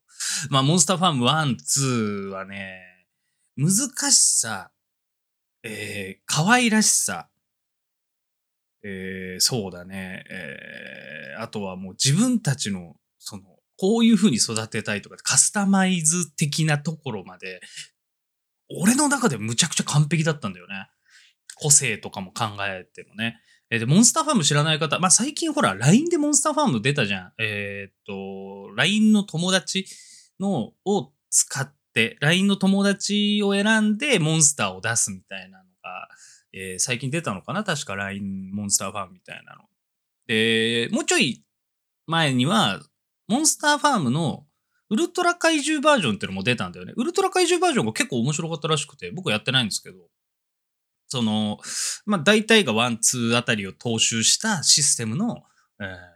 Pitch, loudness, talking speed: 150 Hz, -21 LUFS, 335 characters per minute